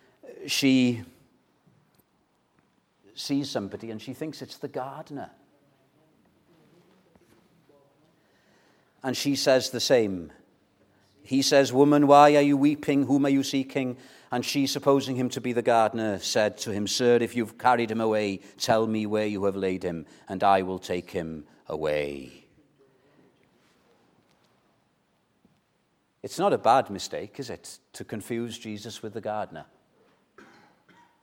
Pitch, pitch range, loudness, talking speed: 120 Hz, 105-140 Hz, -25 LUFS, 130 wpm